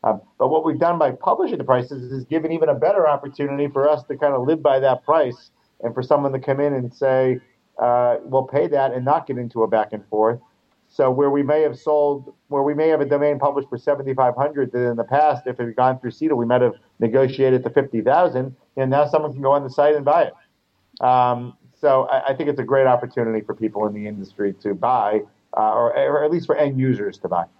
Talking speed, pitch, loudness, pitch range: 250 wpm, 135 Hz, -20 LUFS, 125-145 Hz